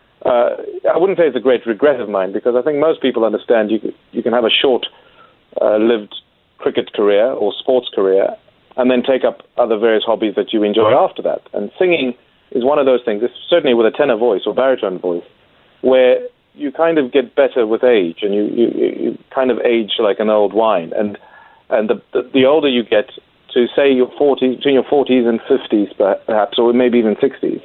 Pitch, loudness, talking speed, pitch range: 125 Hz, -15 LUFS, 210 wpm, 110-140 Hz